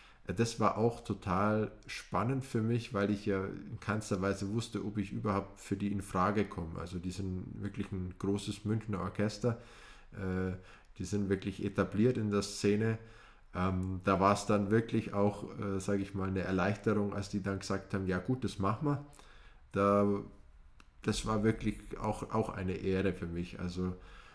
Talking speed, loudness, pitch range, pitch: 165 wpm, -35 LUFS, 95-110 Hz, 100 Hz